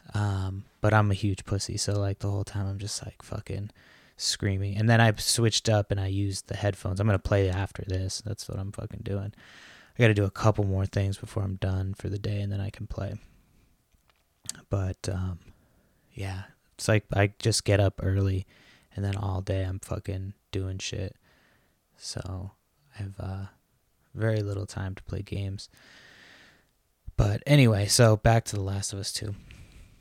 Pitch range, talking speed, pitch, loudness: 95-110 Hz, 185 wpm, 100 Hz, -28 LUFS